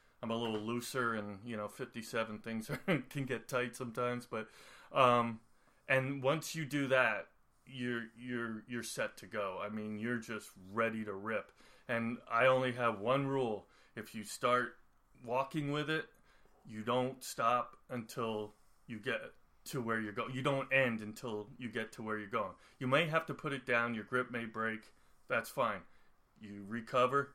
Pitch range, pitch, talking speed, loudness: 110-130 Hz, 120 Hz, 180 wpm, -37 LUFS